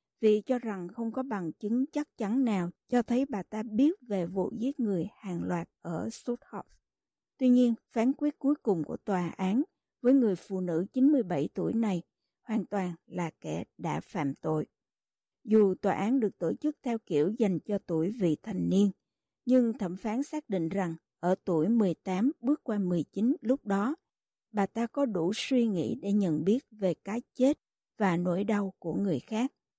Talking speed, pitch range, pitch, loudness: 185 wpm, 185-250 Hz, 215 Hz, -30 LUFS